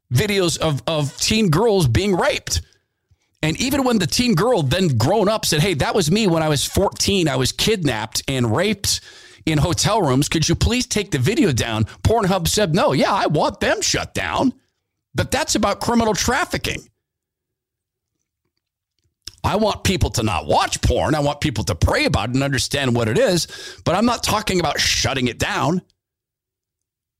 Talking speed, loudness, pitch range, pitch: 180 wpm, -19 LUFS, 115-185 Hz, 145 Hz